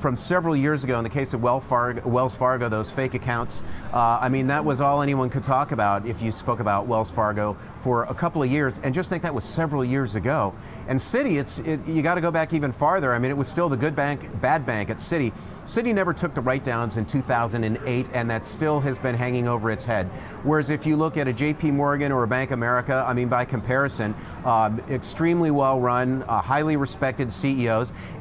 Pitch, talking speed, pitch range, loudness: 130 Hz, 225 wpm, 115-145 Hz, -24 LUFS